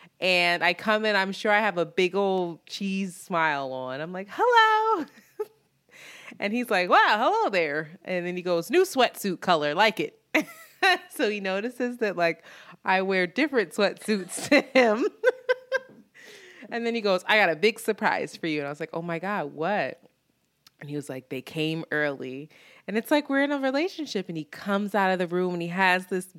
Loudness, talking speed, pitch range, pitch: -25 LUFS, 200 wpm, 170-245 Hz, 195 Hz